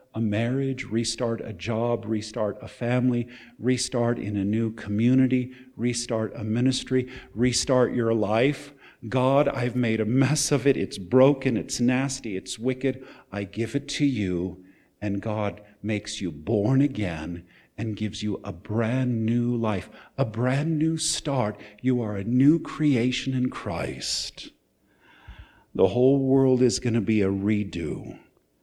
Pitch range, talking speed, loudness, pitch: 105-130 Hz, 145 wpm, -25 LUFS, 120 Hz